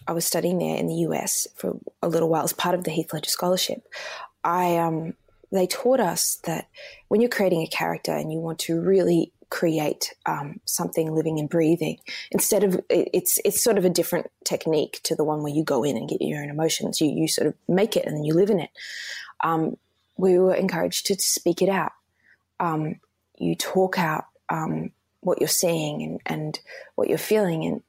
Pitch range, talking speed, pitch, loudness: 160-190 Hz, 205 wpm, 170 Hz, -24 LUFS